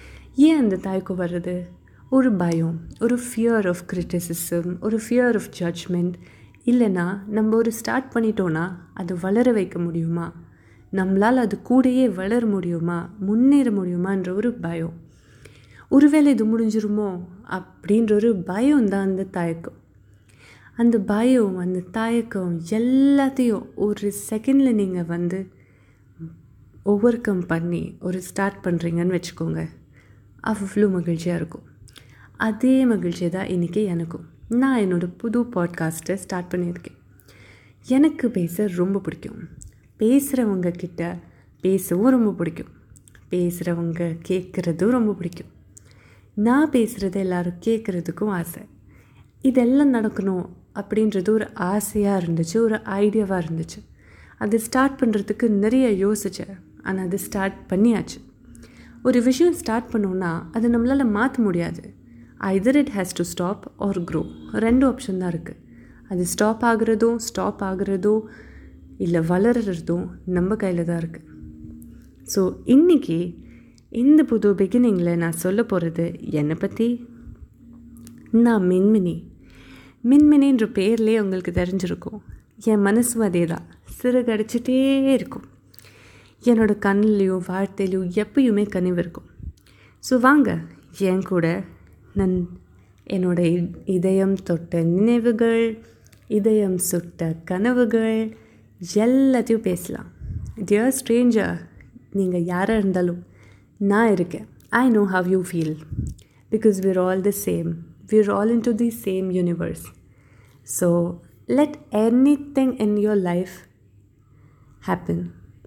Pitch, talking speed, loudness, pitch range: 190 Hz, 100 wpm, -21 LUFS, 170-225 Hz